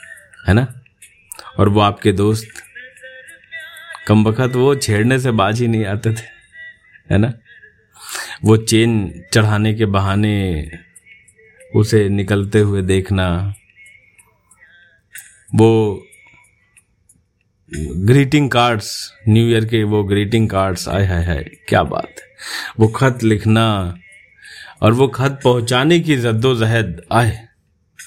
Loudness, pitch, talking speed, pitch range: -16 LUFS, 110 Hz, 110 wpm, 100-120 Hz